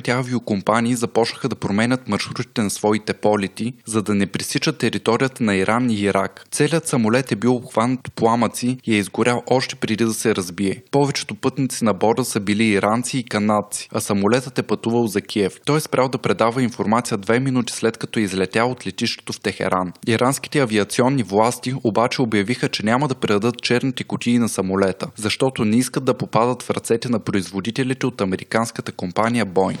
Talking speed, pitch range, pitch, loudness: 180 wpm, 105-125 Hz, 115 Hz, -20 LUFS